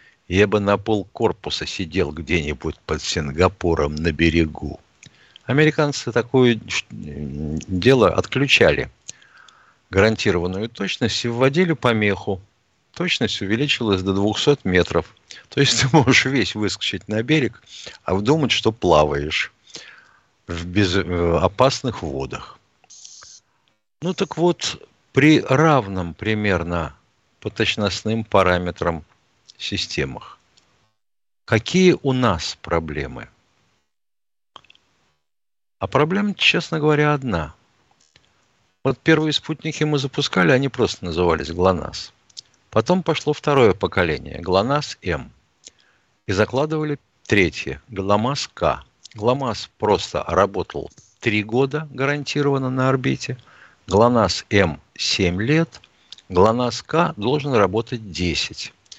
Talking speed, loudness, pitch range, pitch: 95 wpm, -20 LUFS, 90-135 Hz, 110 Hz